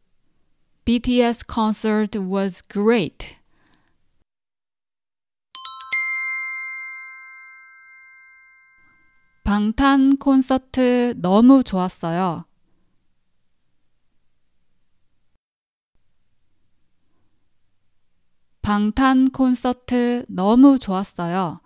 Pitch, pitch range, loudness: 235 Hz, 175-265 Hz, -19 LUFS